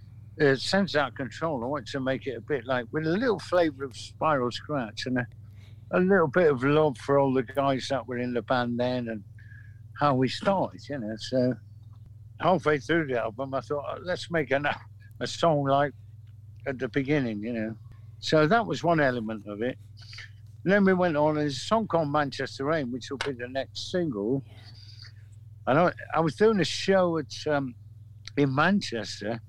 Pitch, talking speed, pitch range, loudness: 130 Hz, 190 wpm, 110-150 Hz, -27 LUFS